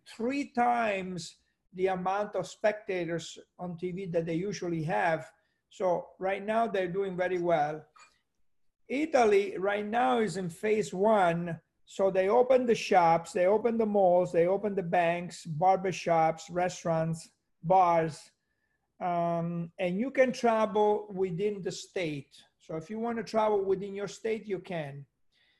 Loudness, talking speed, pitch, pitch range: -29 LUFS, 145 wpm, 190 Hz, 170-210 Hz